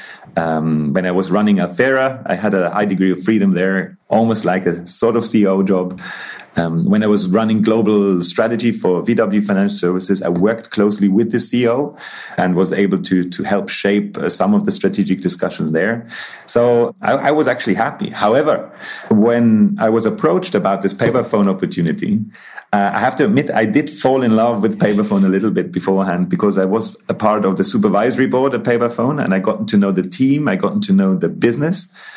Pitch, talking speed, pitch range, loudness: 105 Hz, 200 wpm, 95-120 Hz, -16 LUFS